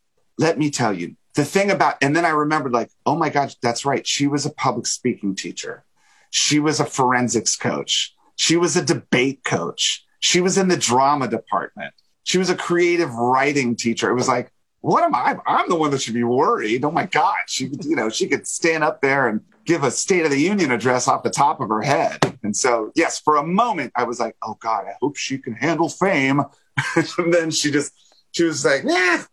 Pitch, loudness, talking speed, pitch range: 150 Hz, -20 LUFS, 220 wpm, 135-170 Hz